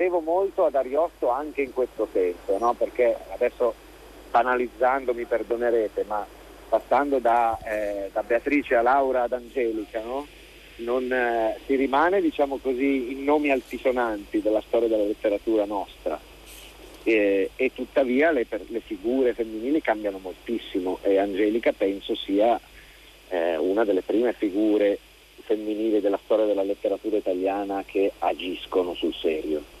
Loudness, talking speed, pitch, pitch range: -25 LUFS, 130 wpm, 115 Hz, 105-135 Hz